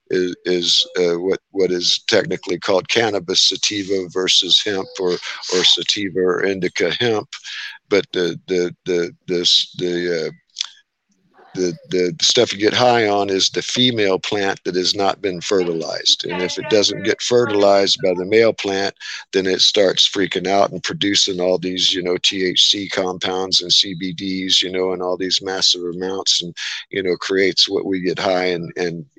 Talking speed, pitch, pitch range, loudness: 170 wpm, 95 Hz, 90-100 Hz, -17 LUFS